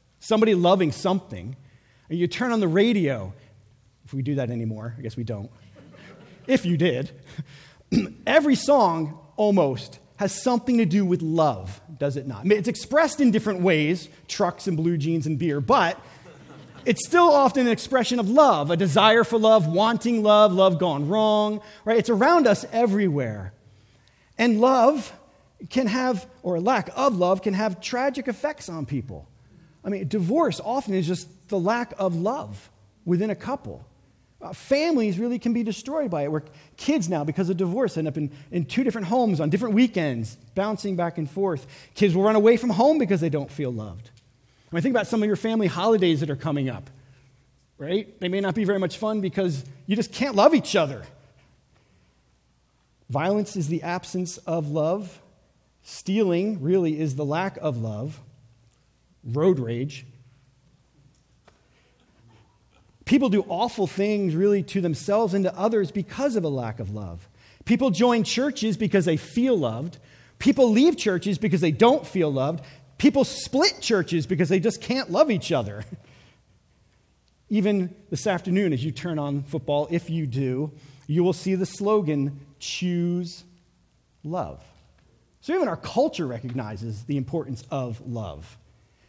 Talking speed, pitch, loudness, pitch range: 165 wpm, 180 Hz, -23 LUFS, 140-215 Hz